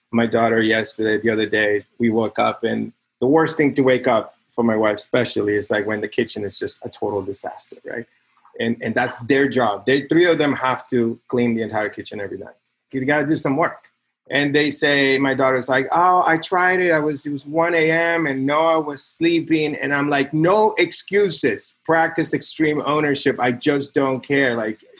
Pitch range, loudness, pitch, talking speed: 120-160 Hz, -19 LUFS, 140 Hz, 205 wpm